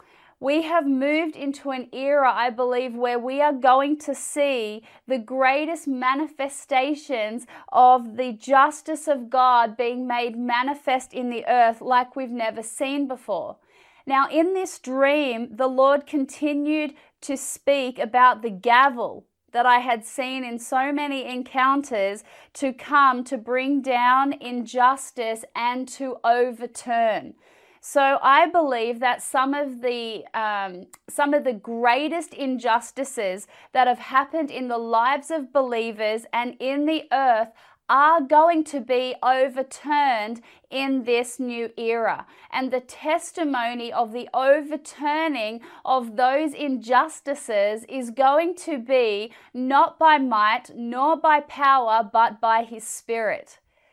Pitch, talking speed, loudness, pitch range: 260 Hz, 130 wpm, -22 LUFS, 240-290 Hz